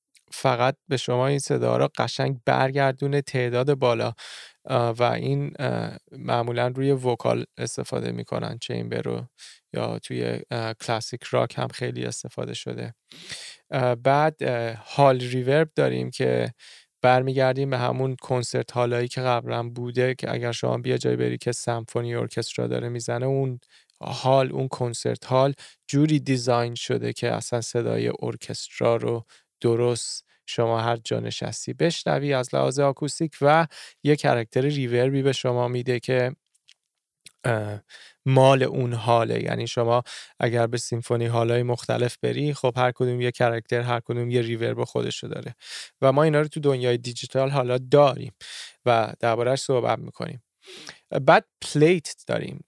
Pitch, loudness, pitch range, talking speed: 125 Hz, -24 LUFS, 115-135 Hz, 135 wpm